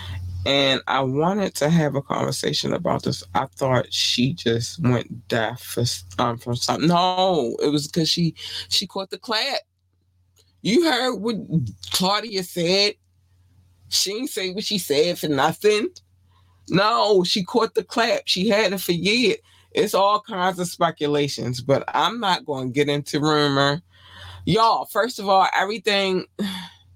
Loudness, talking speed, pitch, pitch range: -21 LUFS, 155 wpm, 155 Hz, 115-195 Hz